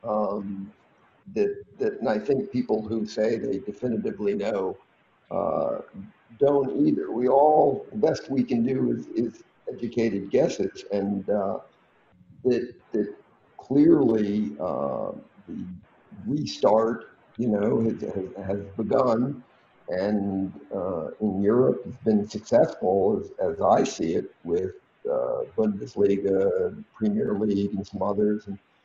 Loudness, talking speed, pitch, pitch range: -25 LUFS, 125 wpm, 110 Hz, 100-150 Hz